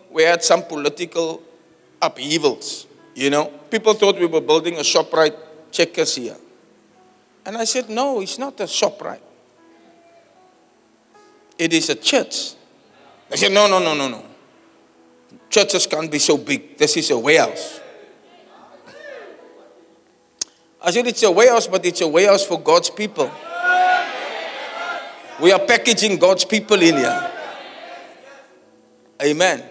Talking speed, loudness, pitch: 135 wpm, -17 LUFS, 205 Hz